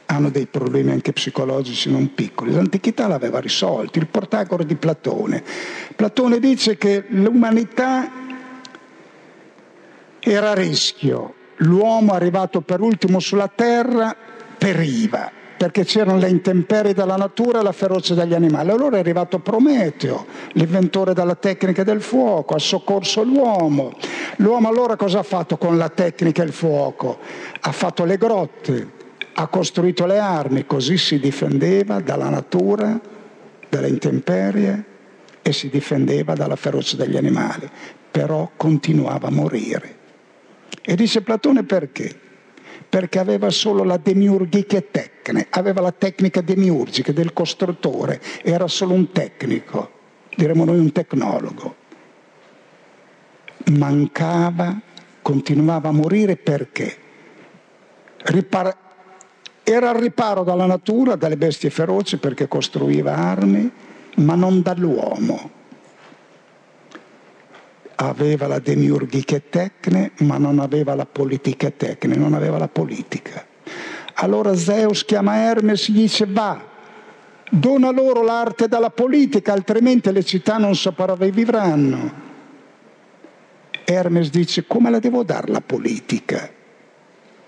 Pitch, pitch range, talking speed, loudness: 190 Hz, 165-215 Hz, 120 wpm, -18 LUFS